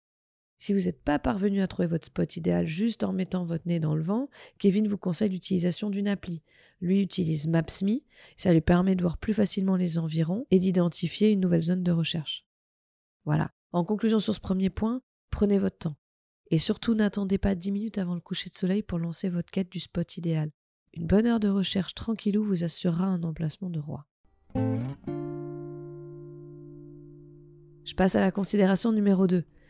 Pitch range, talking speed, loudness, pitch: 160-200 Hz, 180 wpm, -27 LUFS, 180 Hz